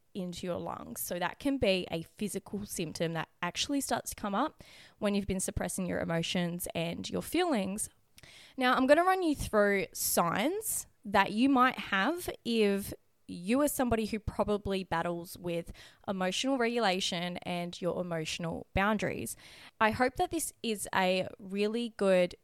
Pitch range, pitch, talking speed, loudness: 180-245 Hz, 200 Hz, 160 wpm, -32 LUFS